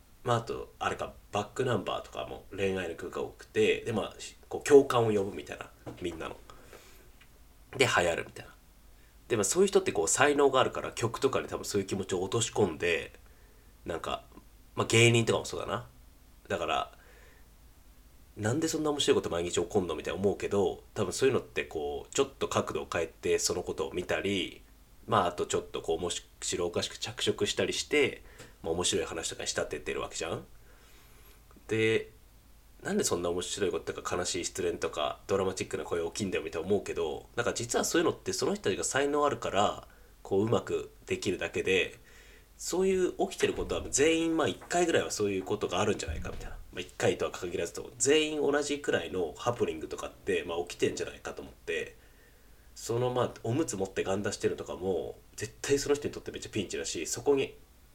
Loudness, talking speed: -31 LUFS, 420 characters per minute